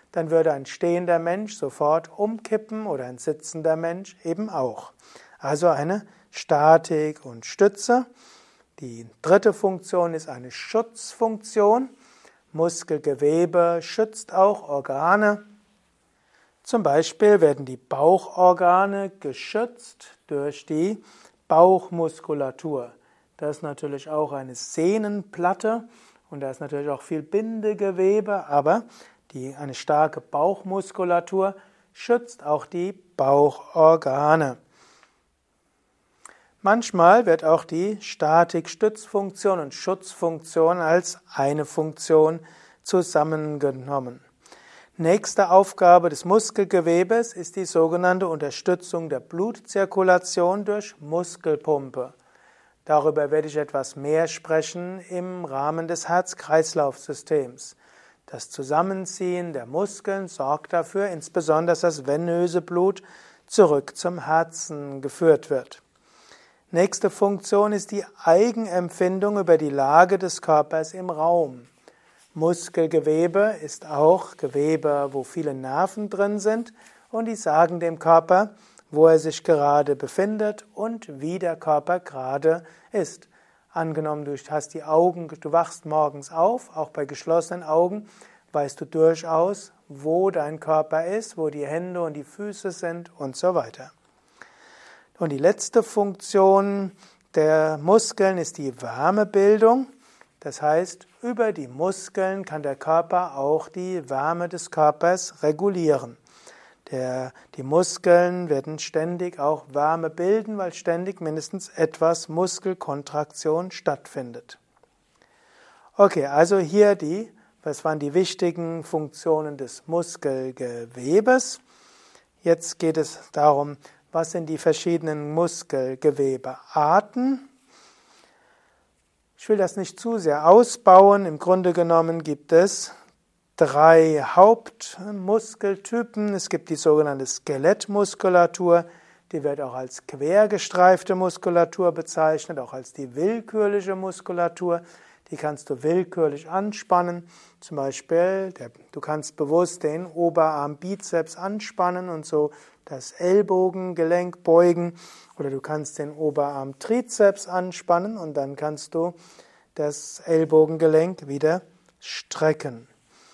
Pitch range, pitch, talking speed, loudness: 155-195 Hz, 170 Hz, 110 wpm, -22 LUFS